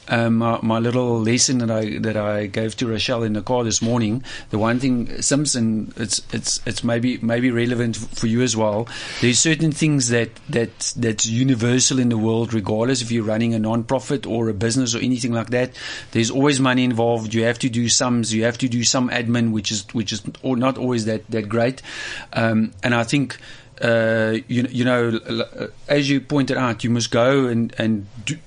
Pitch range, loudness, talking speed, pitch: 115-125 Hz, -20 LUFS, 210 wpm, 120 Hz